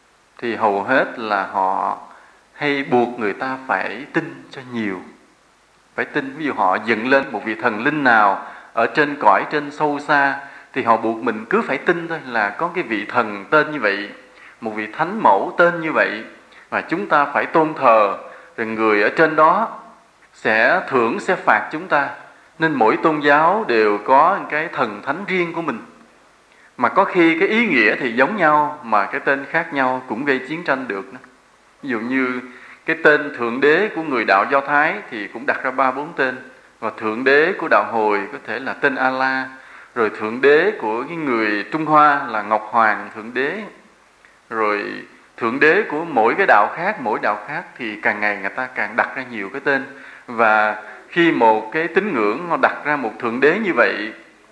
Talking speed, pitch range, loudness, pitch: 200 wpm, 110-150 Hz, -18 LUFS, 130 Hz